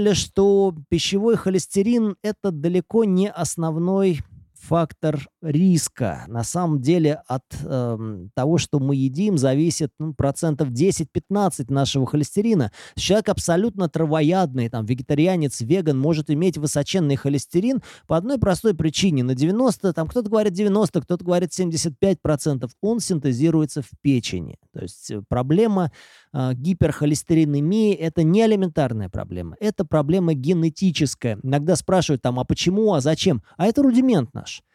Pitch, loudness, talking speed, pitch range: 165 Hz, -21 LUFS, 130 wpm, 140-190 Hz